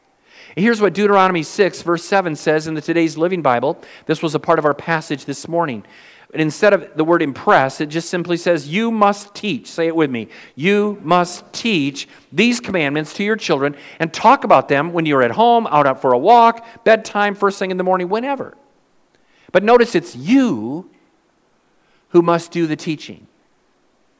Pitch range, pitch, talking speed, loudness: 155-205 Hz, 170 Hz, 185 wpm, -17 LUFS